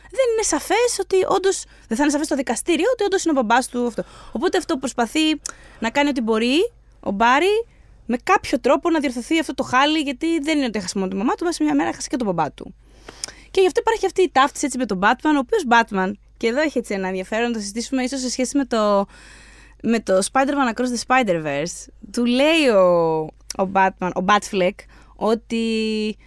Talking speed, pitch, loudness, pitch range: 210 wpm, 255 Hz, -20 LUFS, 220-315 Hz